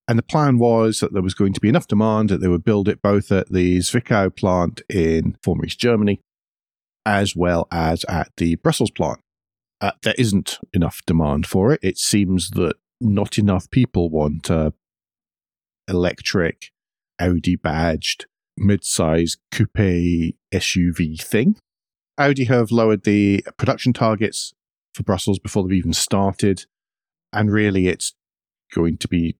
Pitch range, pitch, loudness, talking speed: 85-110 Hz, 95 Hz, -19 LUFS, 150 wpm